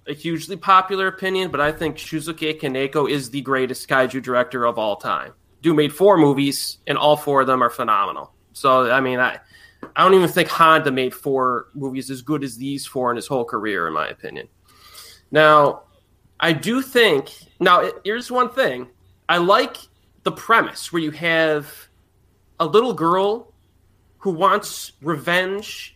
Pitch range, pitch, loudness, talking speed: 130-175 Hz, 145 Hz, -19 LUFS, 170 wpm